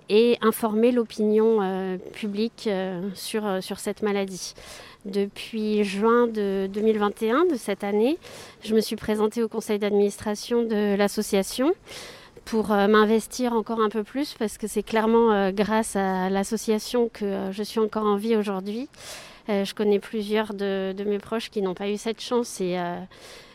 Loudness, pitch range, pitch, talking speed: -25 LUFS, 200-225 Hz, 215 Hz, 170 wpm